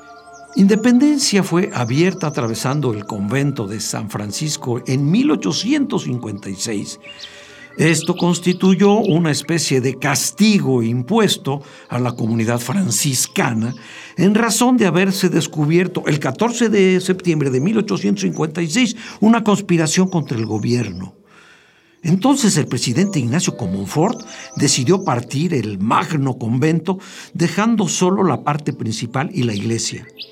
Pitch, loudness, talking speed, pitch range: 160 Hz, -17 LUFS, 110 wpm, 125-195 Hz